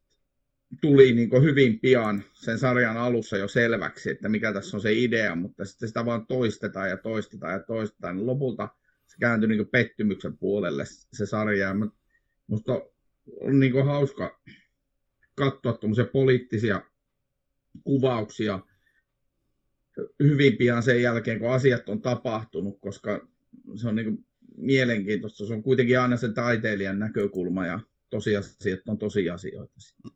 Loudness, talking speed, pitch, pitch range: -25 LUFS, 135 wpm, 115 Hz, 105-125 Hz